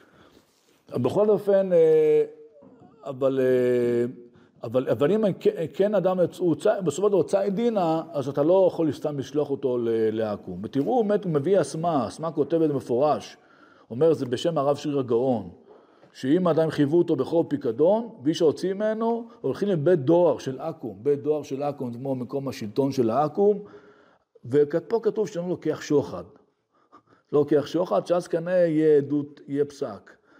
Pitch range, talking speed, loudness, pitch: 140-185 Hz, 145 wpm, -24 LUFS, 155 Hz